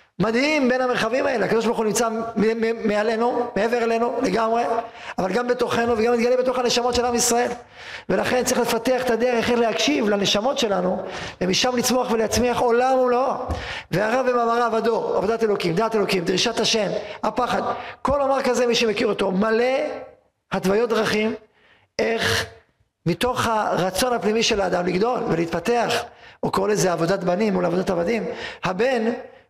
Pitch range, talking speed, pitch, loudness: 215-245 Hz, 145 wpm, 230 Hz, -21 LUFS